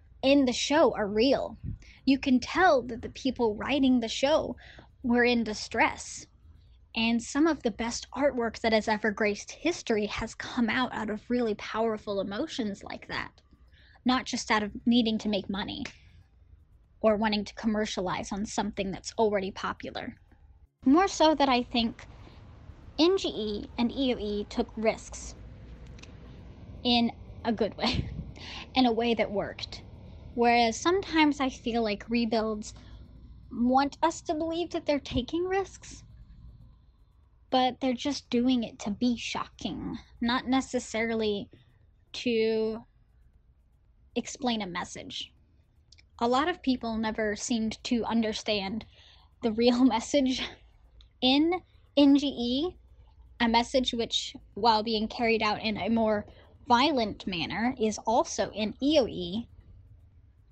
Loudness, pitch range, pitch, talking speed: -28 LUFS, 215-260 Hz, 230 Hz, 130 wpm